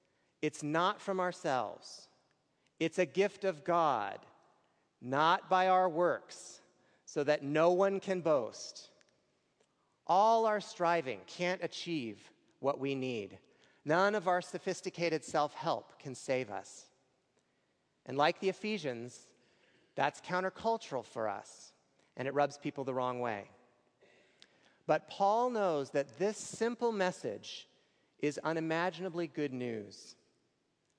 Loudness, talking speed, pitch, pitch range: -34 LUFS, 120 wpm, 165 Hz, 140-185 Hz